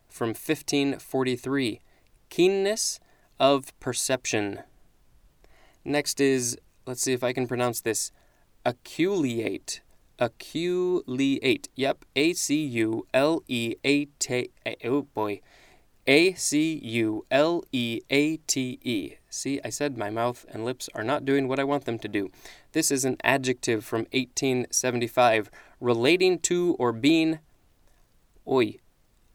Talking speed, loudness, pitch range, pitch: 125 wpm, -26 LUFS, 120-145 Hz, 130 Hz